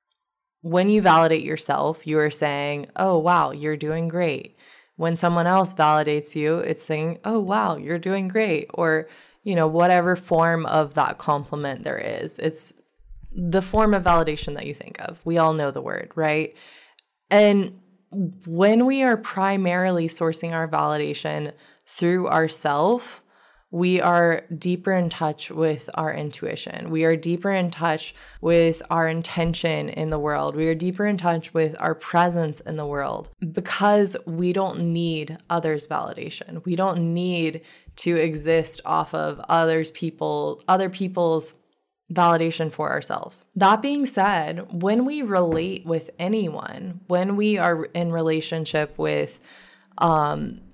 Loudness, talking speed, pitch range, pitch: -22 LUFS, 145 wpm, 155-185 Hz, 165 Hz